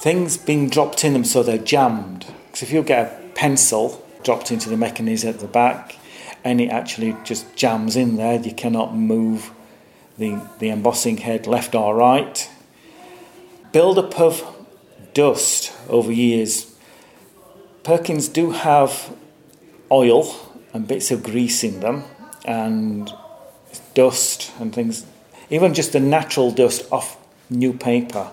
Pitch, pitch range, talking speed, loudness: 125 Hz, 115-160 Hz, 140 wpm, -19 LUFS